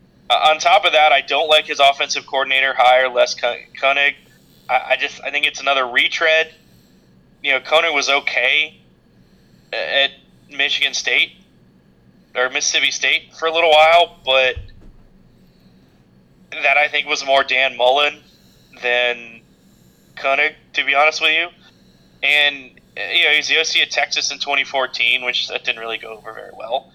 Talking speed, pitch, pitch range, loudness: 155 wpm, 135 Hz, 125-150 Hz, -16 LUFS